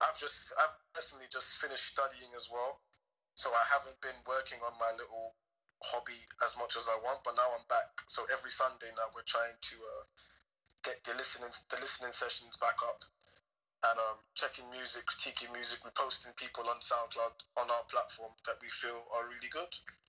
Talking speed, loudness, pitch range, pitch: 185 wpm, -37 LUFS, 115-130 Hz, 120 Hz